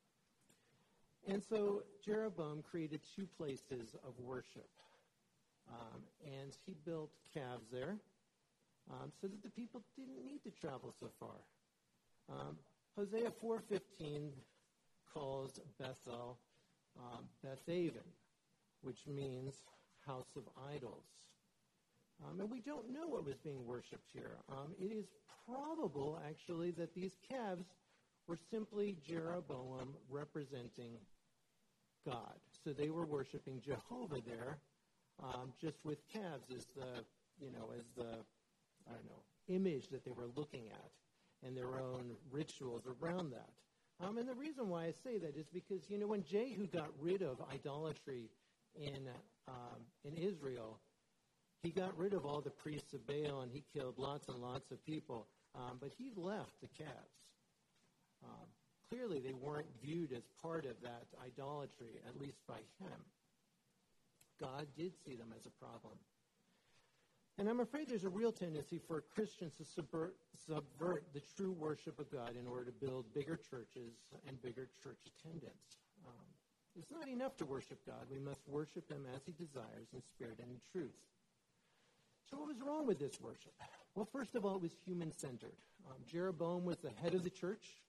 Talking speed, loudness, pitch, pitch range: 155 wpm, -48 LUFS, 150 Hz, 130-185 Hz